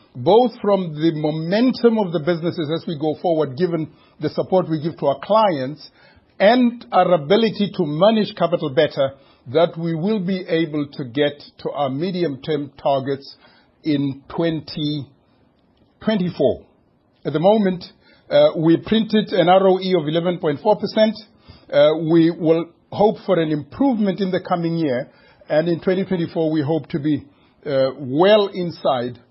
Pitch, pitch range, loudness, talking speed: 170 Hz, 150-195 Hz, -19 LUFS, 145 wpm